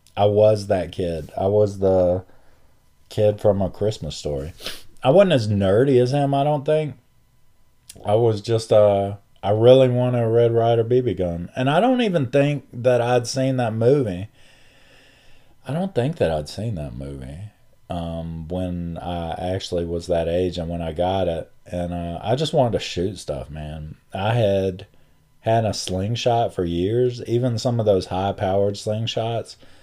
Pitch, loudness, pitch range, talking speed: 105 Hz, -21 LUFS, 90-125 Hz, 175 wpm